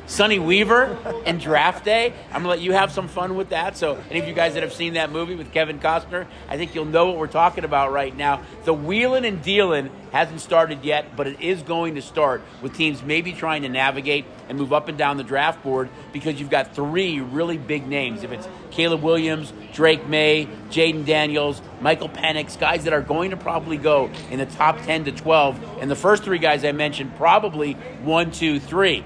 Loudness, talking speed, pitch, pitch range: -21 LUFS, 220 wpm, 155 Hz, 145-170 Hz